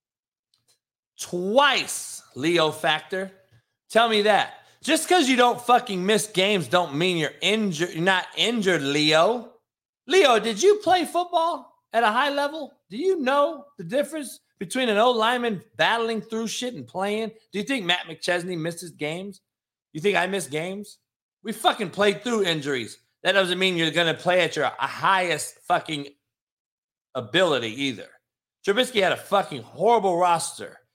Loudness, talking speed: -23 LUFS, 155 wpm